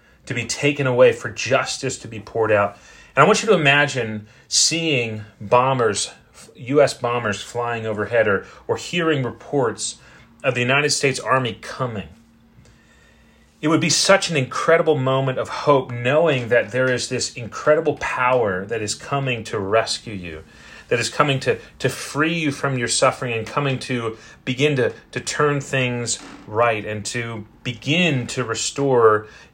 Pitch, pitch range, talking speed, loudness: 125 Hz, 115-140 Hz, 160 wpm, -20 LUFS